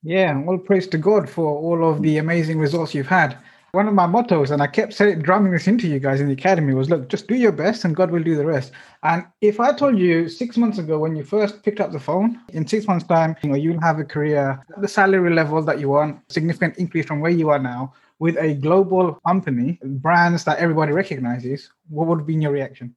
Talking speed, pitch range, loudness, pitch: 245 wpm, 150-190 Hz, -19 LUFS, 165 Hz